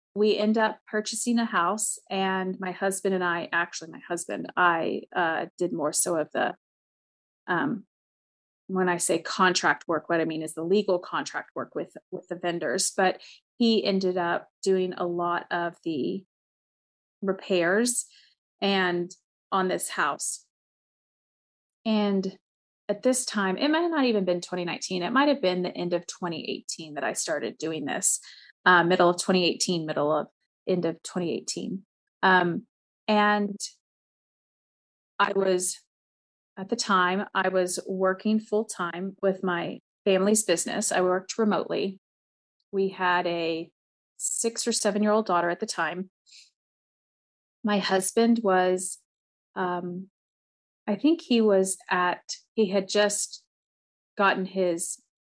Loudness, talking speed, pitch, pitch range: -26 LUFS, 140 wpm, 190 Hz, 175-210 Hz